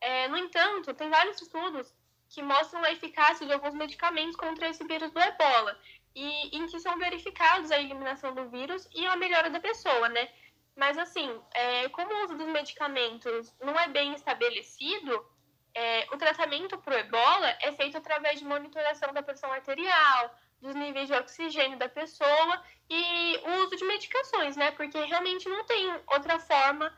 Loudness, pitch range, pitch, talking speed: -29 LUFS, 280-345 Hz, 310 Hz, 170 wpm